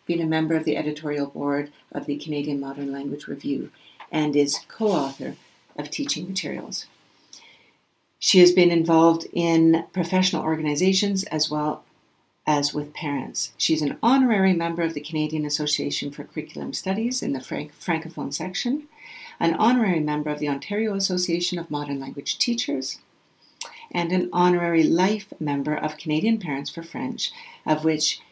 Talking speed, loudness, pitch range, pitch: 150 wpm, -24 LUFS, 150-180 Hz, 160 Hz